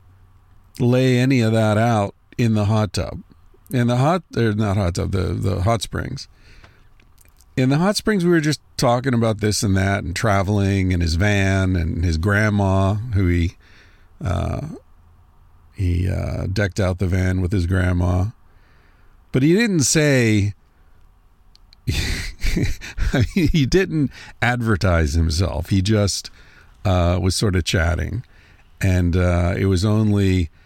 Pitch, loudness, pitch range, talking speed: 95 Hz, -20 LUFS, 90-110 Hz, 140 wpm